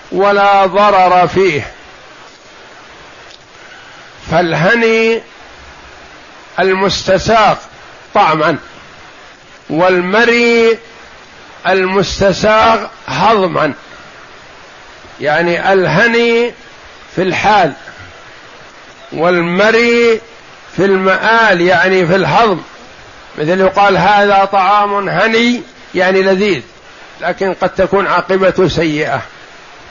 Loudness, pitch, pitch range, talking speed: -11 LUFS, 195 Hz, 185-220 Hz, 60 wpm